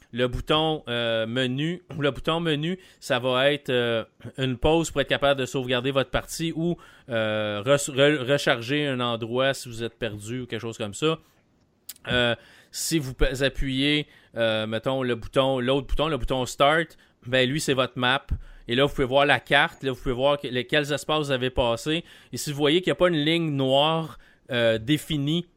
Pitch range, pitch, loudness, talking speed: 125-150 Hz, 135 Hz, -24 LUFS, 195 wpm